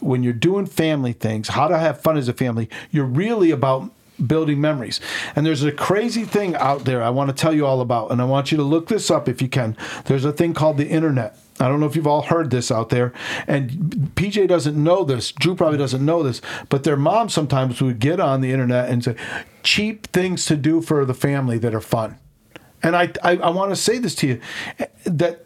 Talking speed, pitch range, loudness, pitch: 235 wpm, 130-170 Hz, -20 LUFS, 150 Hz